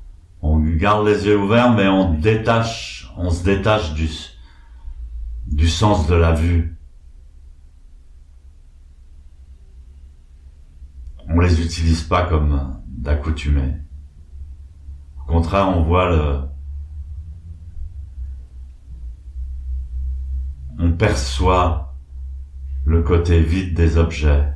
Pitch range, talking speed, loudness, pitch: 65-85 Hz, 85 wpm, -18 LUFS, 75 Hz